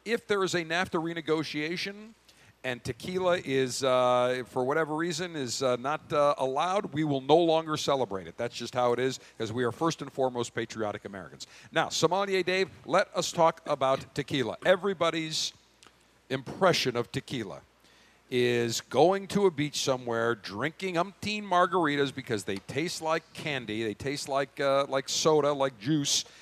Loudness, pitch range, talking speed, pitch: -29 LUFS, 125-170 Hz, 160 wpm, 145 Hz